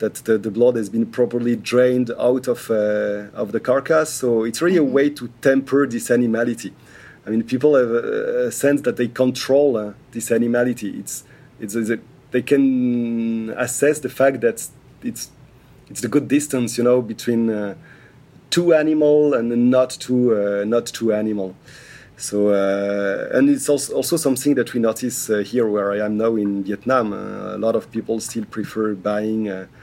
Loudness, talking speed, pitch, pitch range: -19 LUFS, 185 wpm, 120 Hz, 110-135 Hz